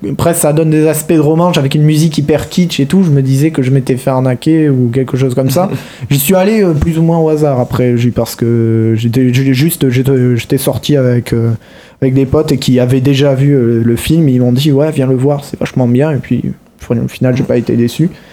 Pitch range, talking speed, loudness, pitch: 125-155 Hz, 230 wpm, -11 LUFS, 135 Hz